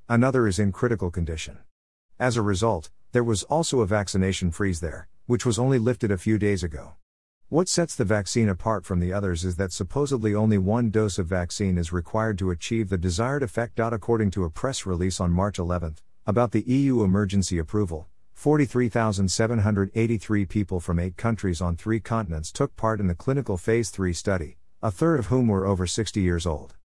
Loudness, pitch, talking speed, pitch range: -25 LUFS, 105 Hz, 185 wpm, 90-115 Hz